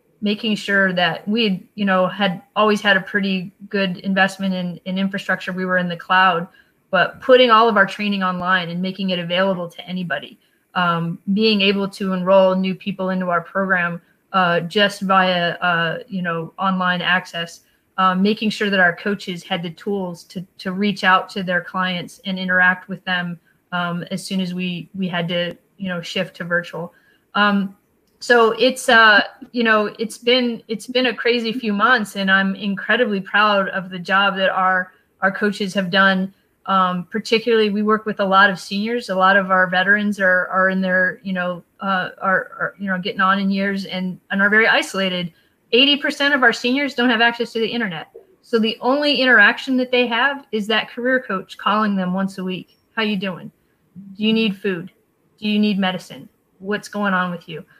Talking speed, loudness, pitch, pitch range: 195 wpm, -18 LUFS, 195 Hz, 185-215 Hz